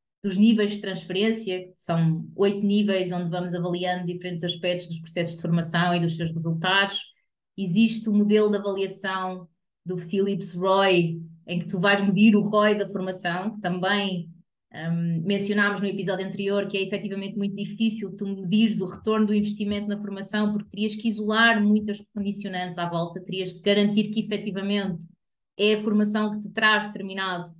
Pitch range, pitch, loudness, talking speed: 180-205 Hz, 195 Hz, -24 LUFS, 170 wpm